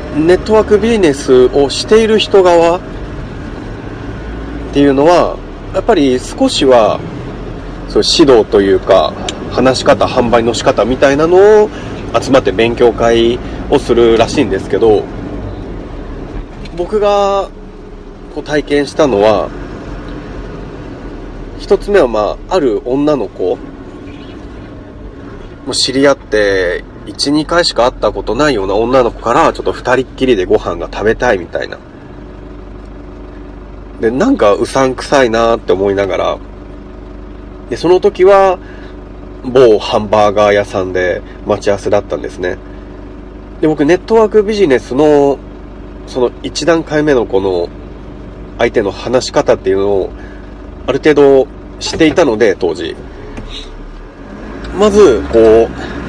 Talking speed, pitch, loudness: 245 characters per minute, 125 Hz, -11 LUFS